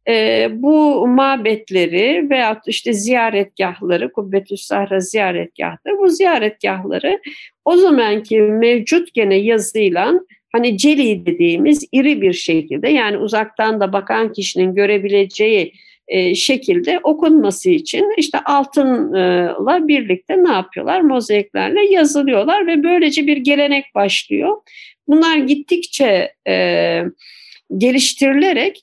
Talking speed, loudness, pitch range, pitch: 100 wpm, -15 LUFS, 205-320 Hz, 270 Hz